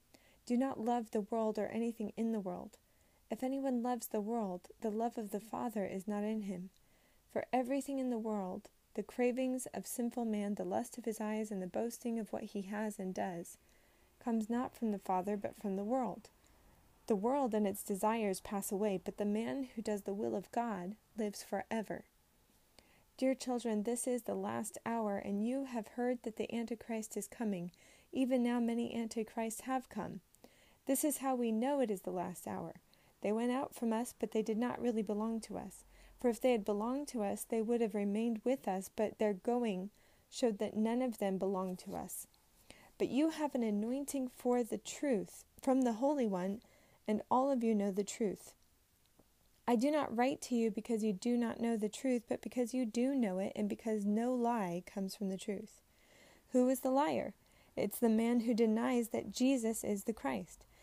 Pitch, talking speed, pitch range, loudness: 225 Hz, 200 wpm, 205-245 Hz, -37 LUFS